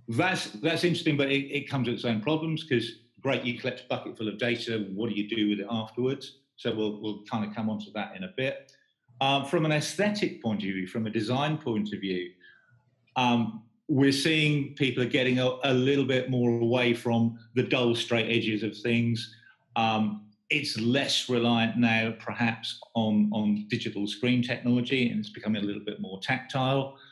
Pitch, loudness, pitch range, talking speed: 120 Hz, -28 LUFS, 110-135 Hz, 200 wpm